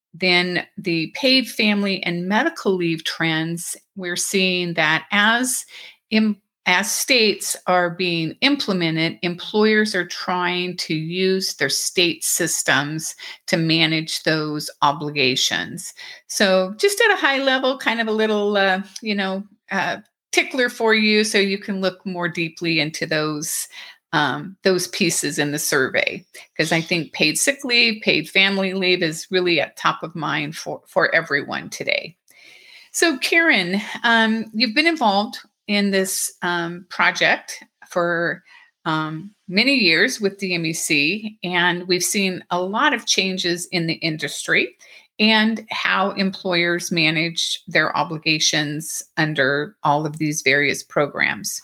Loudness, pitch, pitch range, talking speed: -19 LUFS, 185 Hz, 165-215 Hz, 135 wpm